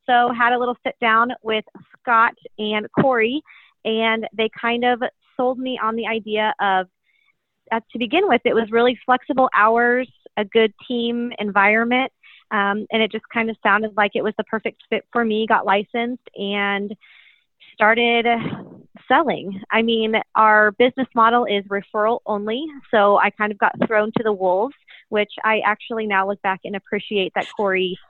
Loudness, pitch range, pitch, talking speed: -19 LUFS, 210-240 Hz, 220 Hz, 170 wpm